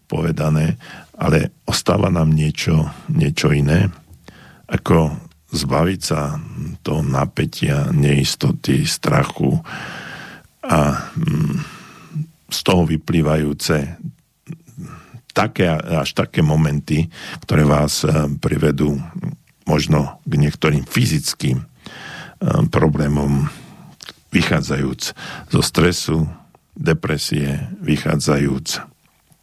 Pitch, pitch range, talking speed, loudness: 75 Hz, 75-80 Hz, 70 wpm, -18 LUFS